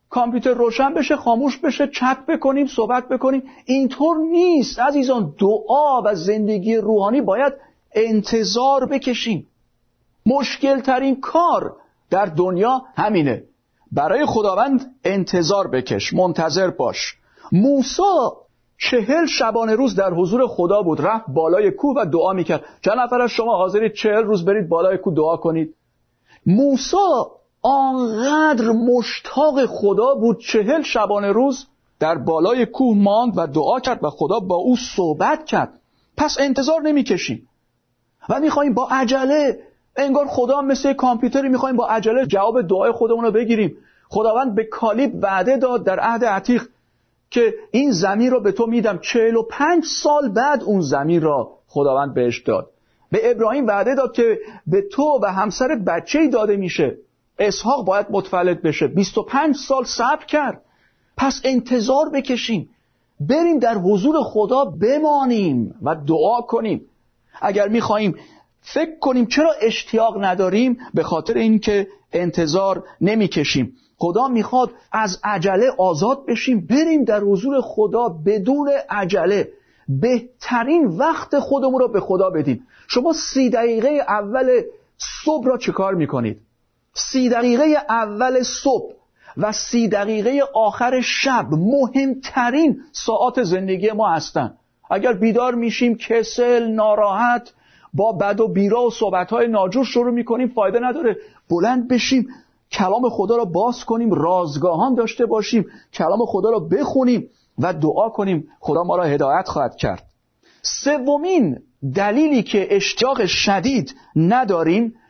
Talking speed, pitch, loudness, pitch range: 130 wpm, 235 Hz, -18 LUFS, 200-270 Hz